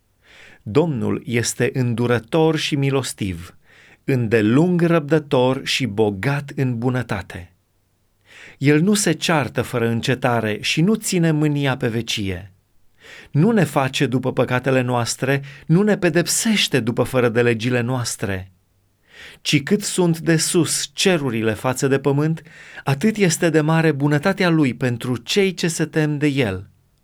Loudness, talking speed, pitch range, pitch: -19 LUFS, 130 wpm, 120-160 Hz, 135 Hz